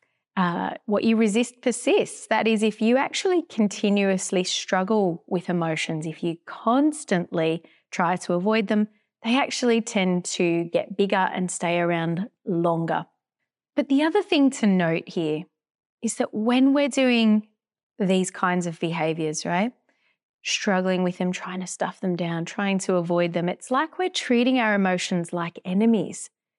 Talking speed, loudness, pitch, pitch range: 155 wpm, -24 LUFS, 195 Hz, 175-230 Hz